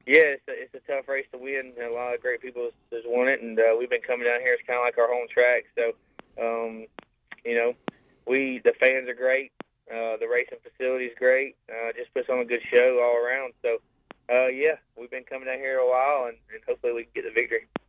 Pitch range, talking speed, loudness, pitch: 120-155 Hz, 250 wpm, -25 LUFS, 130 Hz